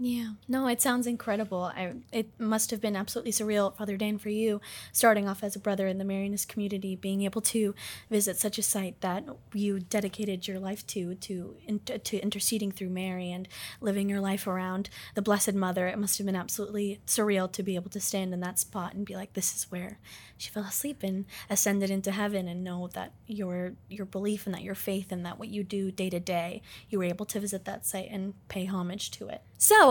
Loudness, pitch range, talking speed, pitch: -31 LUFS, 190-210 Hz, 220 wpm, 200 Hz